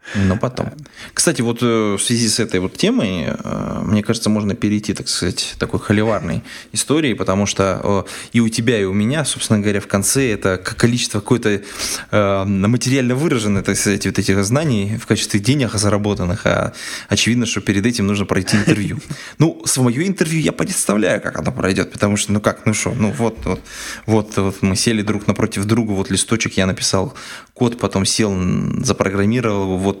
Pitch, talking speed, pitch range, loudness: 105 Hz, 170 wpm, 100-120 Hz, -17 LUFS